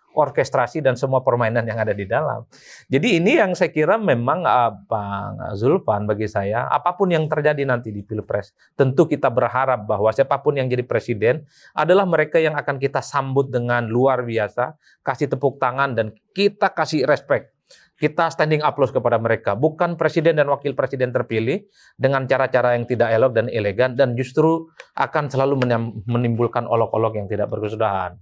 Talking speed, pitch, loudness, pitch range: 160 wpm, 130 Hz, -20 LUFS, 115-150 Hz